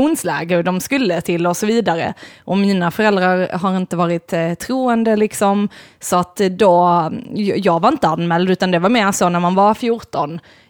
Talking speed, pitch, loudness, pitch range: 170 wpm, 185 Hz, -16 LUFS, 175-215 Hz